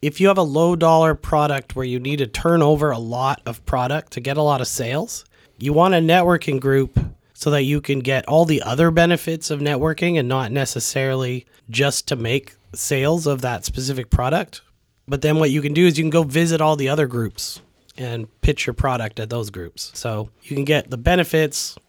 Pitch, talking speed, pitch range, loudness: 140 Hz, 215 wpm, 125-155 Hz, -19 LUFS